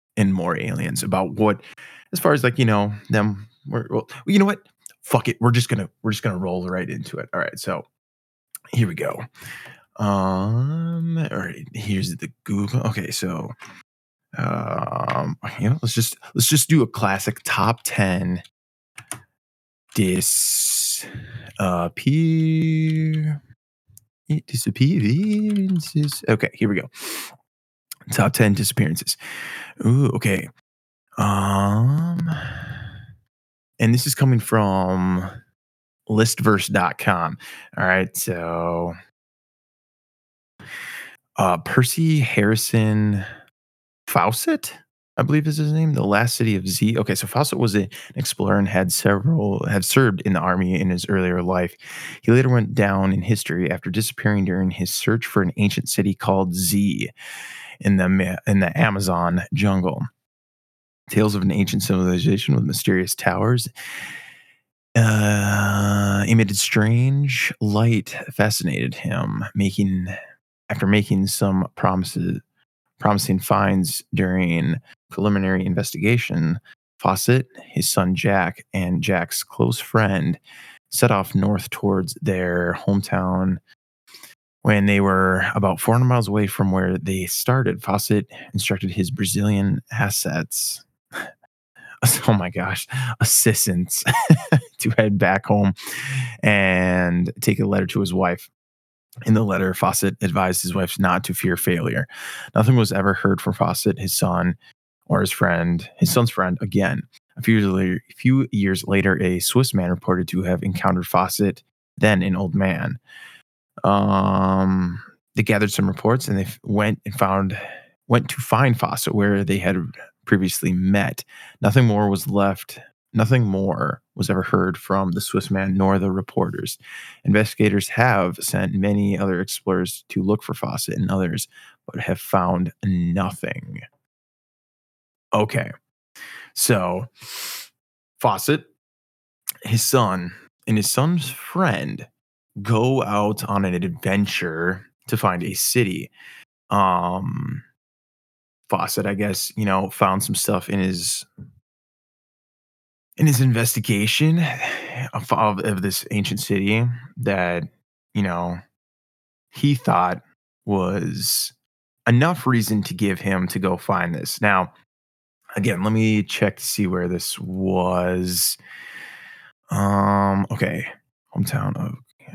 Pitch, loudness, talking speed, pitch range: 100 Hz, -21 LUFS, 125 wpm, 95-120 Hz